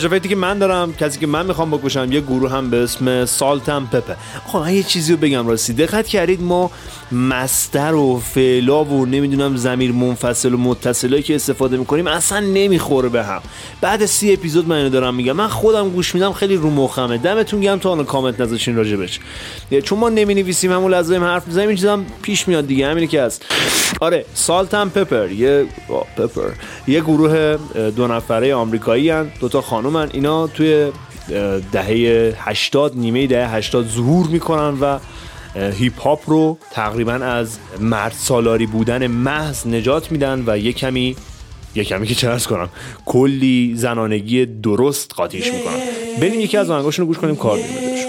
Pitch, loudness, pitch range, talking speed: 140 Hz, -17 LUFS, 120-175 Hz, 165 wpm